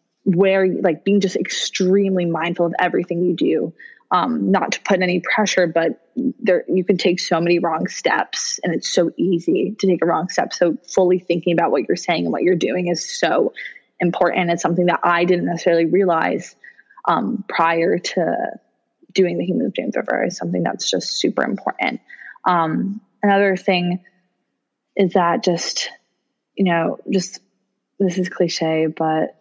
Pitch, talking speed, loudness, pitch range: 180 Hz, 170 wpm, -19 LUFS, 175-195 Hz